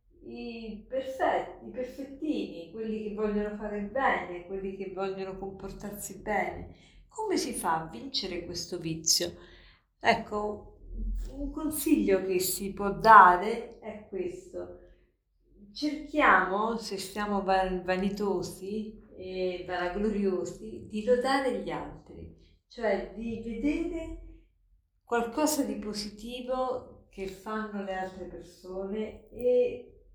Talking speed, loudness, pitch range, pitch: 105 wpm, -29 LUFS, 185-235 Hz, 205 Hz